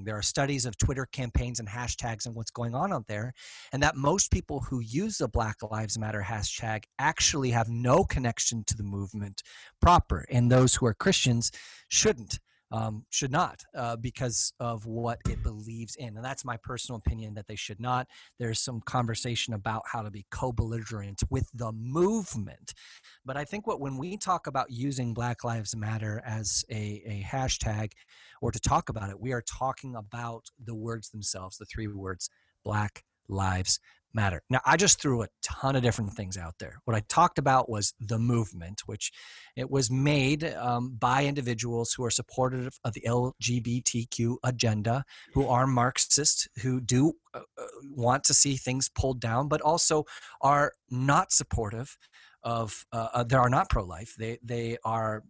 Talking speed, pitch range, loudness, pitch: 175 wpm, 110-130 Hz, -28 LUFS, 120 Hz